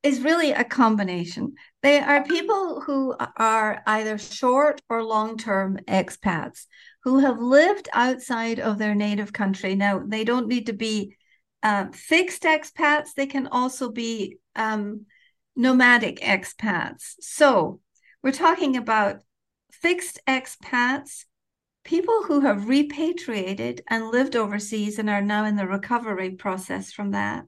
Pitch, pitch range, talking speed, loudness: 240 Hz, 210-285 Hz, 135 wpm, -23 LUFS